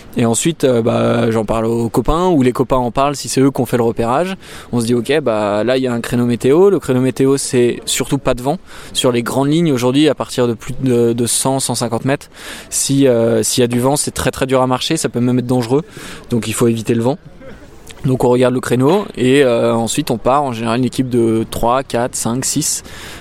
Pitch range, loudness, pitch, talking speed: 115-135 Hz, -15 LUFS, 125 Hz, 250 wpm